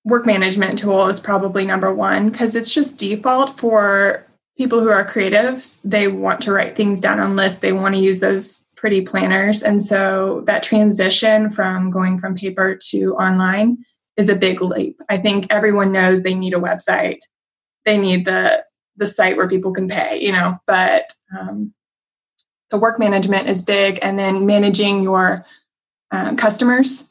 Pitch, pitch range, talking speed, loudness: 200 Hz, 190-215 Hz, 170 wpm, -16 LUFS